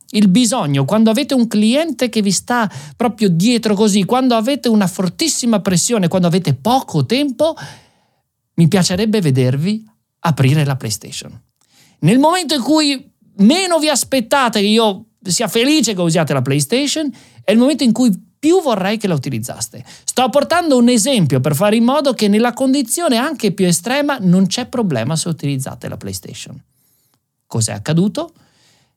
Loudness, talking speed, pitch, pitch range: -15 LUFS, 155 wpm, 220 Hz, 175-260 Hz